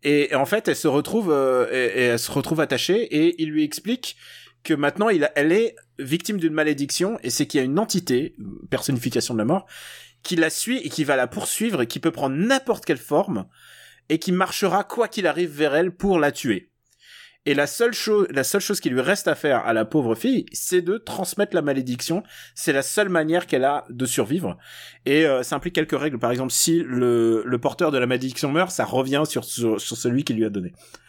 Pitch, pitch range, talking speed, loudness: 155 Hz, 130-185 Hz, 230 wpm, -22 LUFS